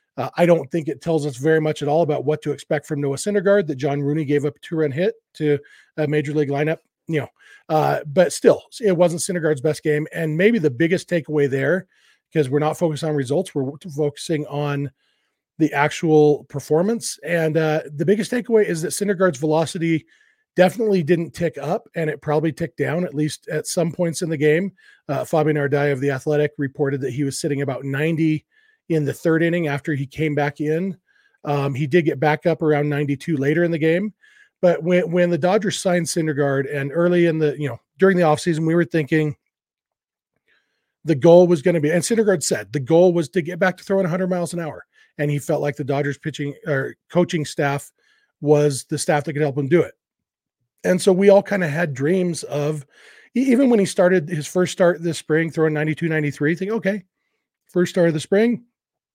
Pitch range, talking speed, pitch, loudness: 150-180 Hz, 210 wpm, 160 Hz, -20 LUFS